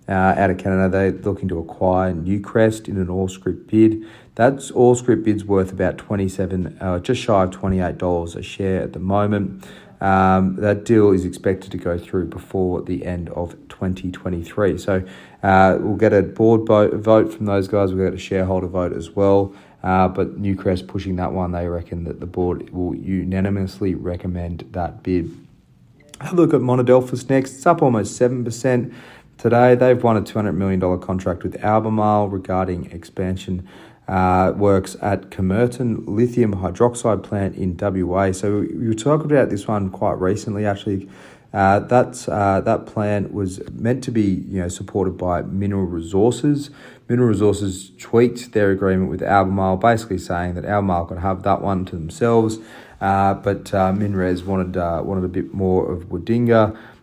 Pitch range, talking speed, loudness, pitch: 95-110 Hz, 165 wpm, -19 LUFS, 95 Hz